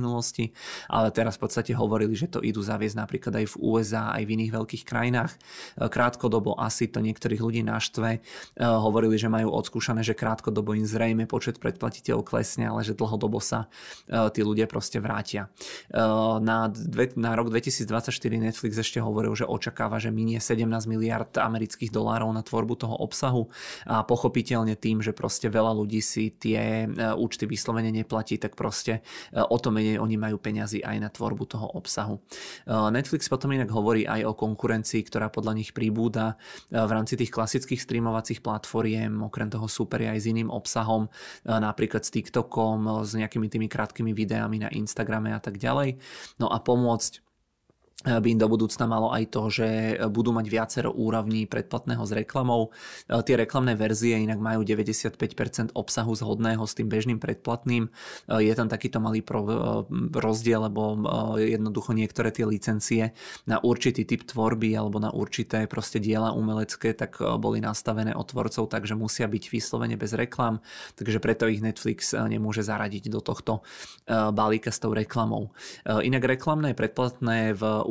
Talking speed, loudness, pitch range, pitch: 155 wpm, -27 LUFS, 110-115 Hz, 110 Hz